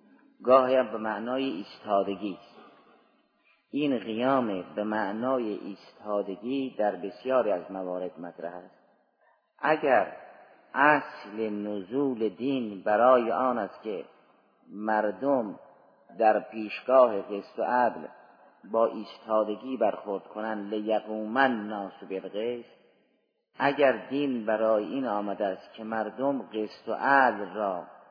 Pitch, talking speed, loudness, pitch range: 110 Hz, 105 wpm, -28 LUFS, 105-130 Hz